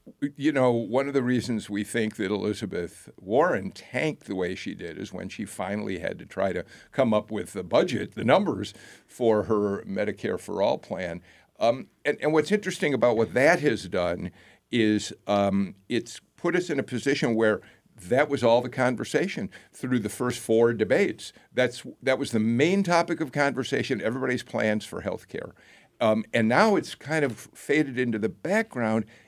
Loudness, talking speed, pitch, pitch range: -26 LUFS, 180 wpm, 120 Hz, 110-140 Hz